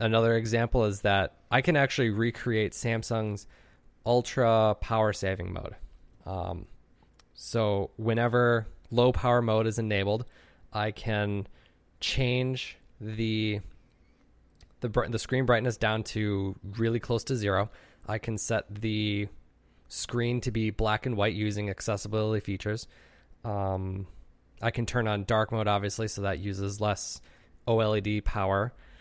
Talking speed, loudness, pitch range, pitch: 130 wpm, -29 LUFS, 100-115 Hz, 110 Hz